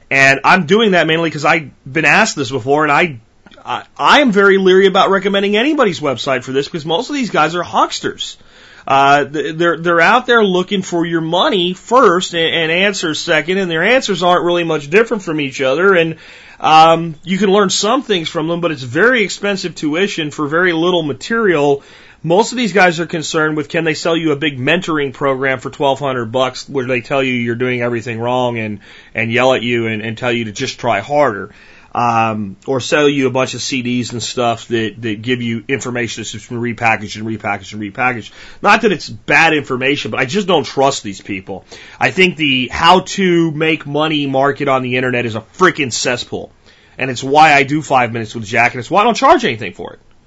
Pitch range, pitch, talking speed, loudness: 125-175 Hz, 145 Hz, 215 wpm, -14 LUFS